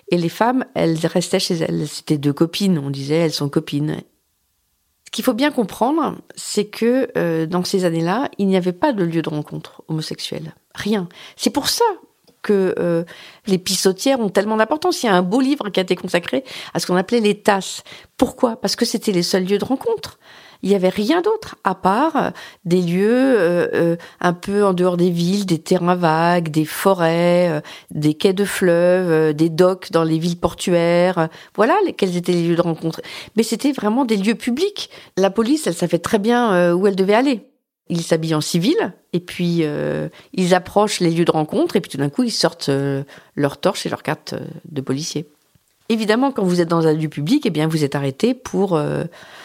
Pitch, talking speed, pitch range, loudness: 180 Hz, 210 wpm, 165-215 Hz, -19 LUFS